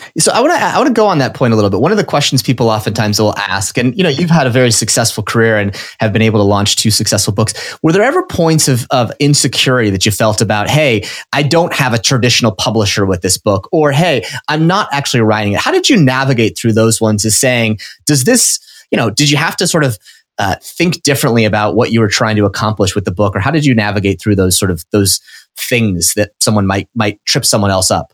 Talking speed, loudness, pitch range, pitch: 250 wpm, -11 LUFS, 105-140 Hz, 115 Hz